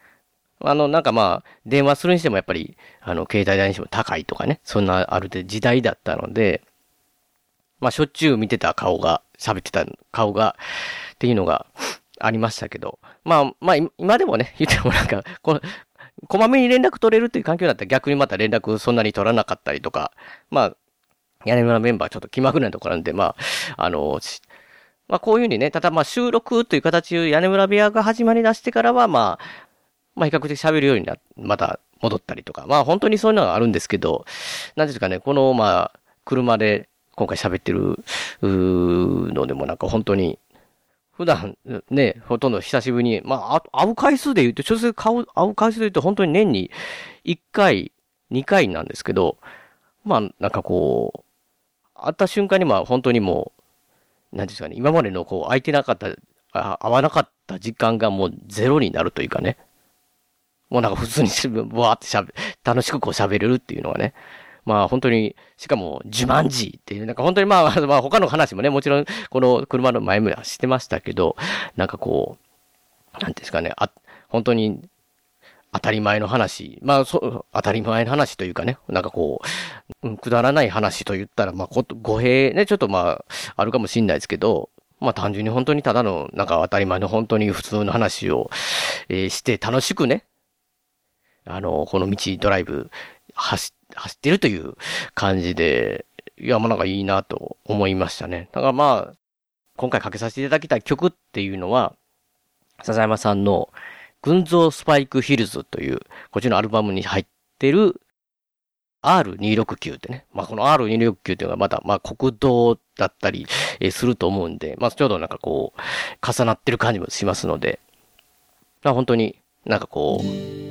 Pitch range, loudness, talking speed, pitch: 105-155 Hz, -20 LUFS, 360 characters per minute, 120 Hz